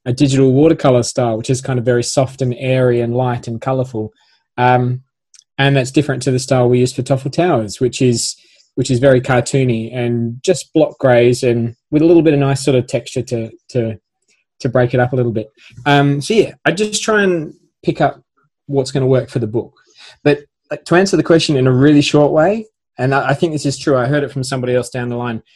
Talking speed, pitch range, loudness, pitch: 230 wpm, 125-145 Hz, -15 LUFS, 130 Hz